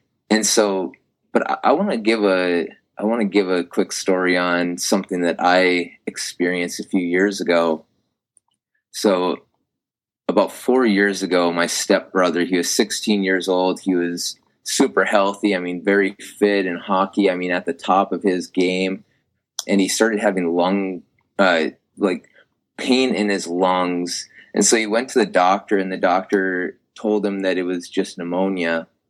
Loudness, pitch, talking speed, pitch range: -19 LUFS, 95 Hz, 170 wpm, 90-100 Hz